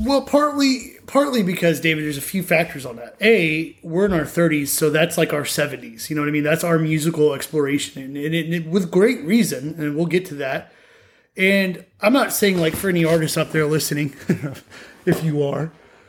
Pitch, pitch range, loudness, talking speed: 165 Hz, 150-190 Hz, -20 LUFS, 205 wpm